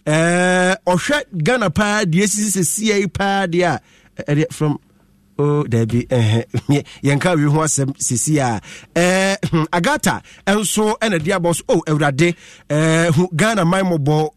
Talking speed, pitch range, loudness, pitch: 130 wpm, 145-190 Hz, -17 LUFS, 170 Hz